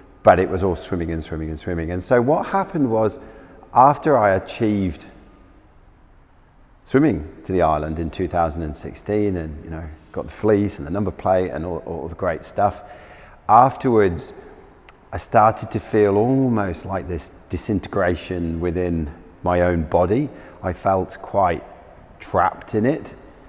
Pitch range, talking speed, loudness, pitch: 85-105 Hz, 150 wpm, -20 LUFS, 90 Hz